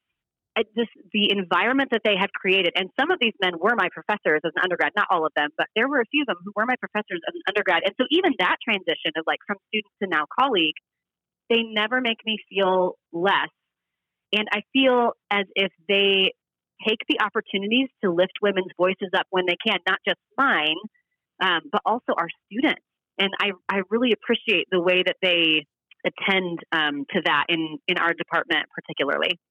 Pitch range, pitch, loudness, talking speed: 180-225 Hz, 195 Hz, -23 LUFS, 200 wpm